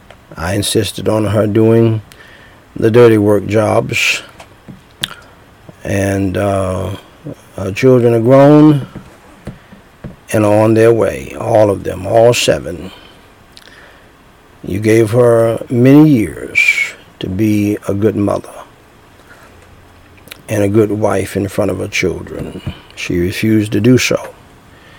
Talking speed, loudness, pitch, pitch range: 120 wpm, -12 LUFS, 110 Hz, 100-115 Hz